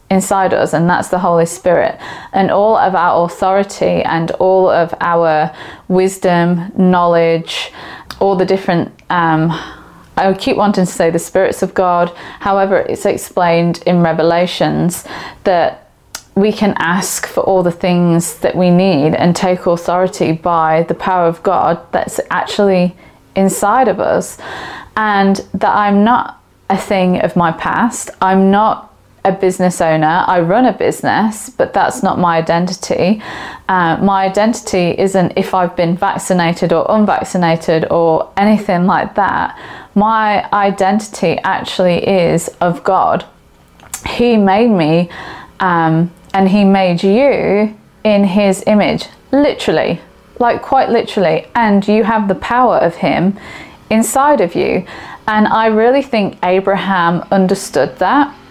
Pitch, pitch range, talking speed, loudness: 190 Hz, 175-200 Hz, 140 wpm, -13 LUFS